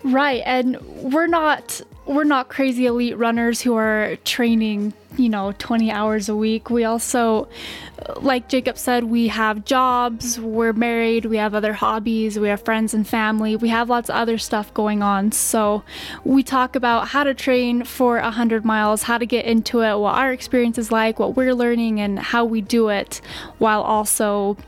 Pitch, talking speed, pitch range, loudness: 230 Hz, 185 wpm, 215-245 Hz, -19 LUFS